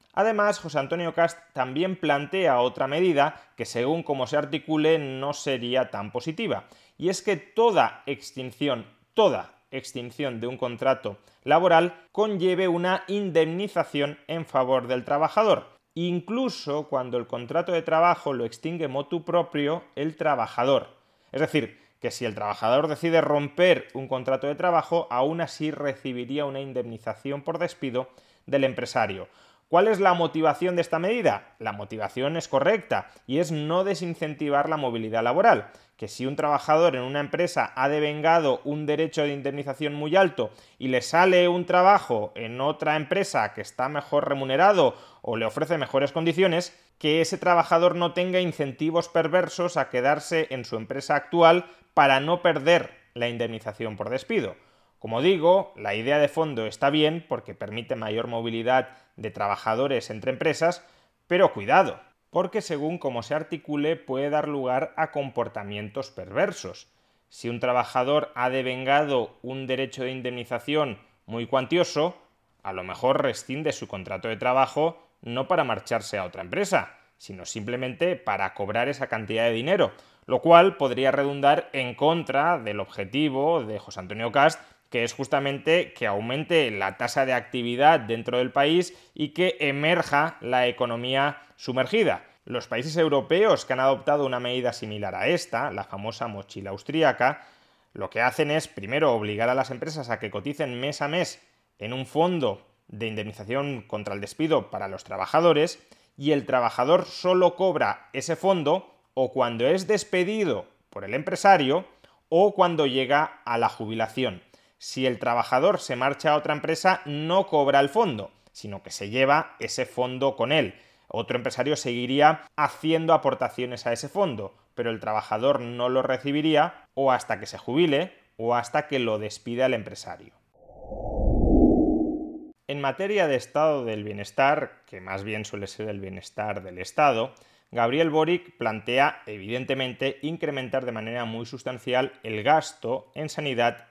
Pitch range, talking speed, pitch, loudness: 125-165 Hz, 150 wpm, 140 Hz, -25 LUFS